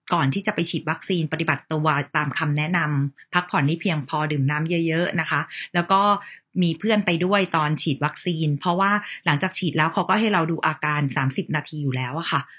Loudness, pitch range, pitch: -23 LUFS, 150-180 Hz, 160 Hz